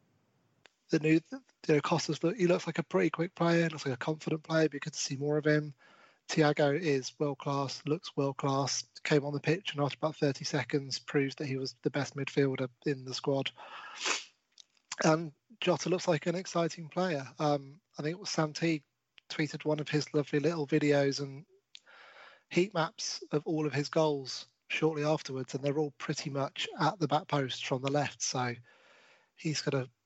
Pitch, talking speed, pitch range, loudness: 150 Hz, 195 wpm, 140-165 Hz, -32 LUFS